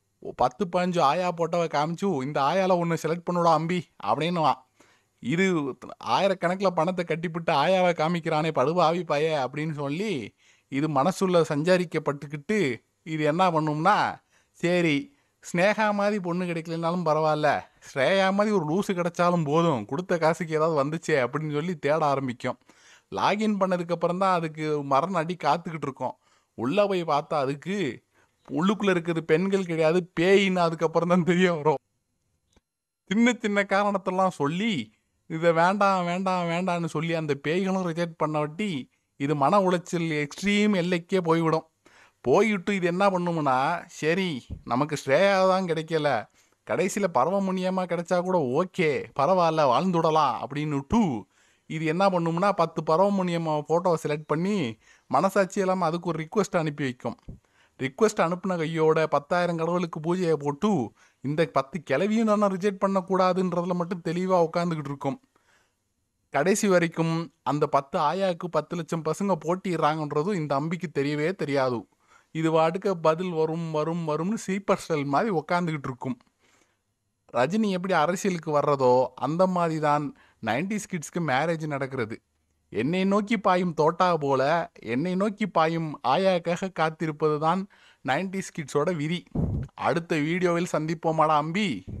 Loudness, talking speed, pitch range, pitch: -25 LUFS, 125 wpm, 150-185 Hz, 170 Hz